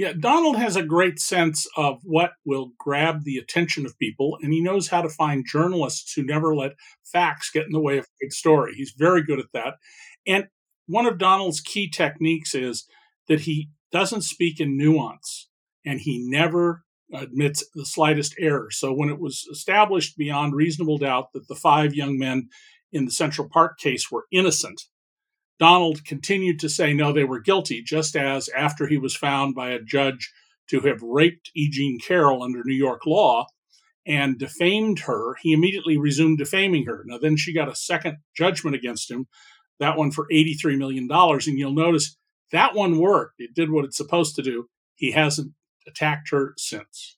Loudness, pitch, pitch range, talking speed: -22 LUFS, 155 Hz, 140-170 Hz, 185 wpm